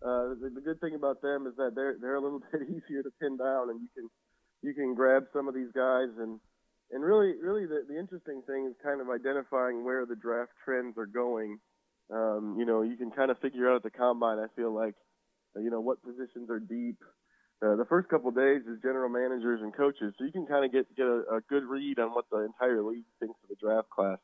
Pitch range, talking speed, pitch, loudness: 115-135 Hz, 245 wpm, 125 Hz, -32 LUFS